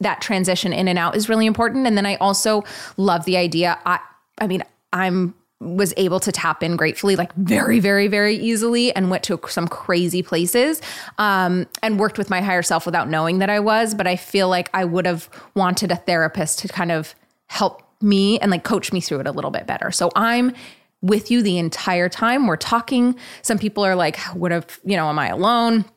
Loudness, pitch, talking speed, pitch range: -19 LUFS, 190 Hz, 215 wpm, 175-215 Hz